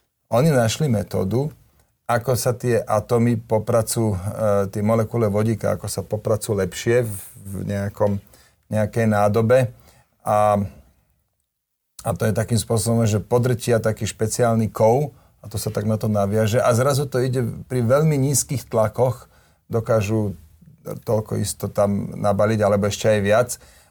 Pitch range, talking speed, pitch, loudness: 105-120 Hz, 135 wpm, 110 Hz, -21 LUFS